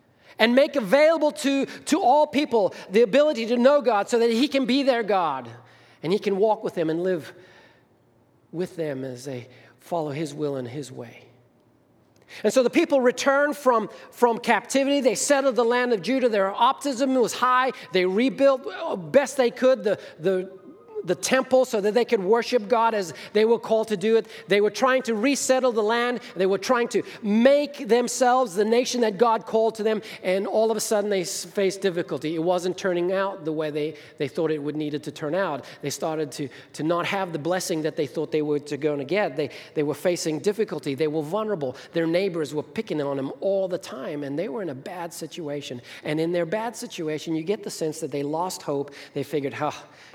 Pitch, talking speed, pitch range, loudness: 200 Hz, 215 wpm, 160-245 Hz, -24 LUFS